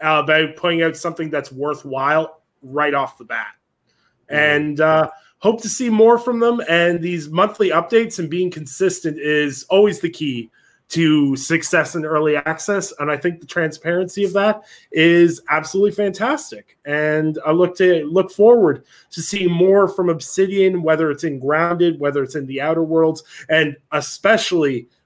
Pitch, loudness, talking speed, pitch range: 160 Hz, -18 LUFS, 165 wpm, 150-185 Hz